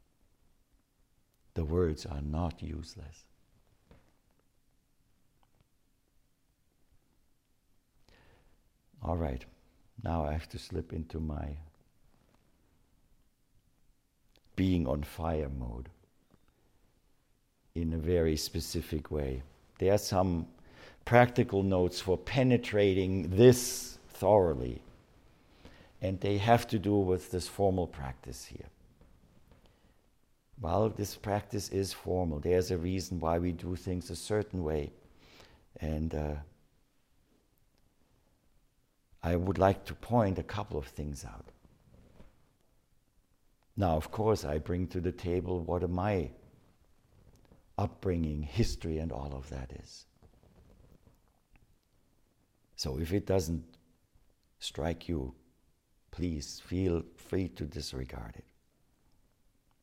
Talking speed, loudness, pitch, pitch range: 100 wpm, -32 LUFS, 85 Hz, 80-95 Hz